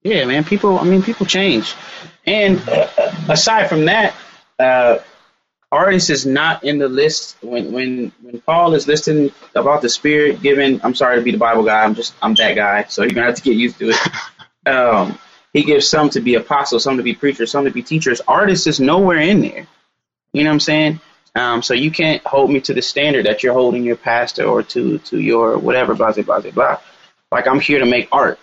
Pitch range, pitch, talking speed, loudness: 125-160 Hz, 145 Hz, 215 wpm, -15 LUFS